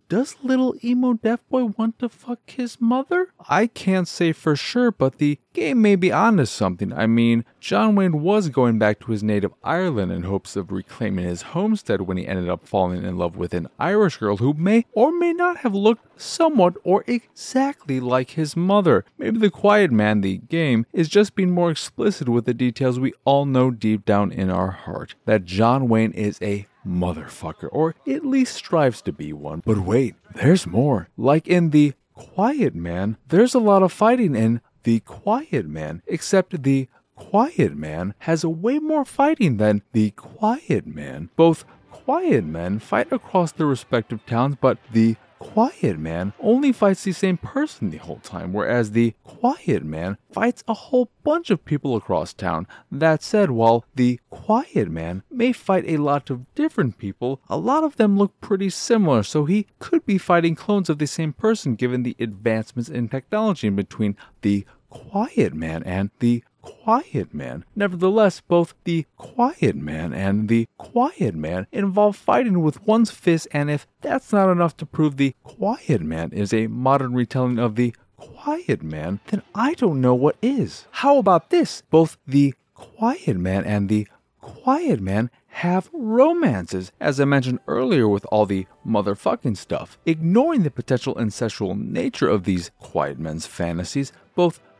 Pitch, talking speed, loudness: 145 Hz, 175 wpm, -21 LUFS